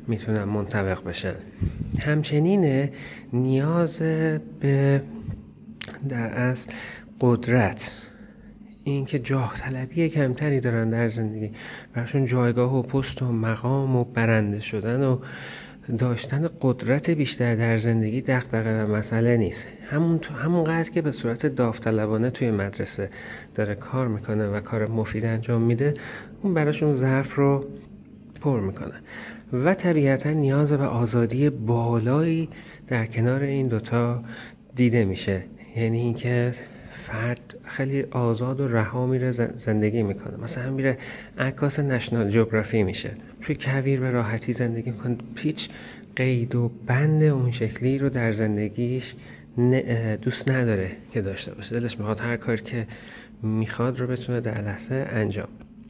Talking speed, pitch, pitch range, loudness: 125 wpm, 120 Hz, 115-135 Hz, -25 LUFS